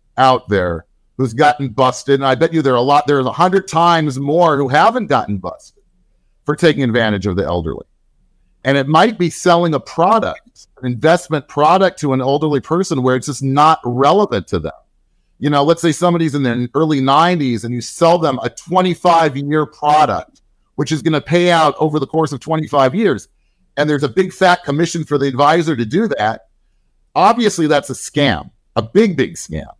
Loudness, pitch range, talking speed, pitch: -15 LUFS, 130-165 Hz, 195 wpm, 145 Hz